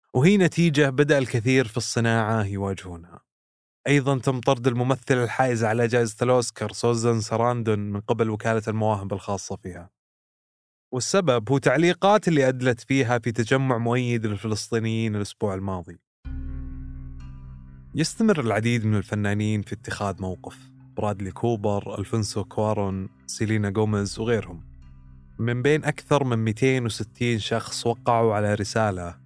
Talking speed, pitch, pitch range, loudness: 120 wpm, 115 Hz, 100-125 Hz, -24 LUFS